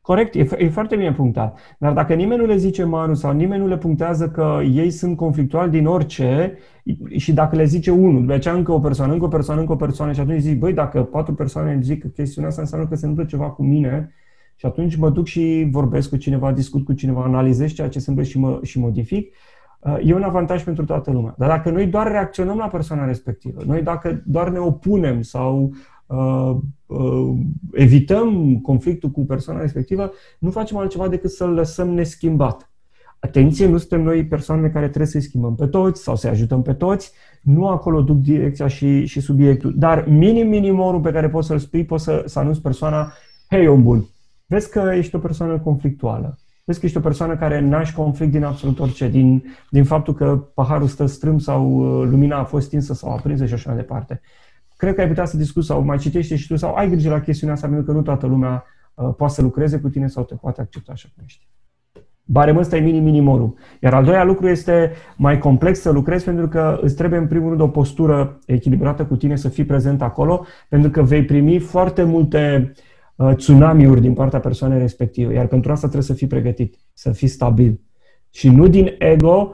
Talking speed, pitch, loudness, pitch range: 210 wpm, 150 Hz, -17 LUFS, 135-165 Hz